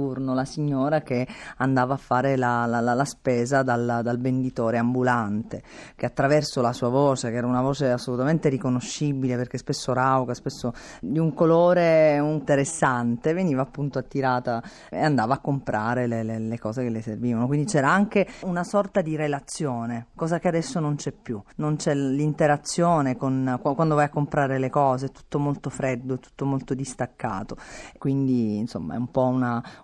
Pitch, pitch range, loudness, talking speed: 135 Hz, 125-150 Hz, -24 LUFS, 170 wpm